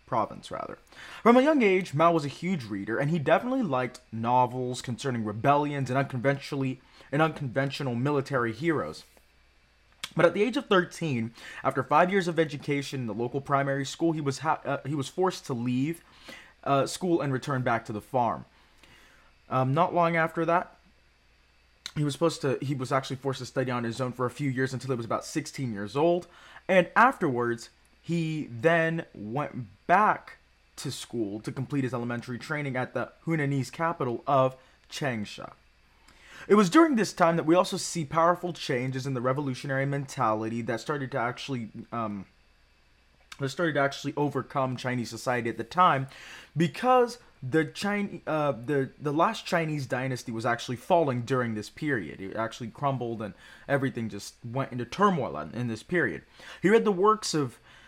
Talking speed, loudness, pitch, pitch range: 175 wpm, -28 LUFS, 135 Hz, 120-165 Hz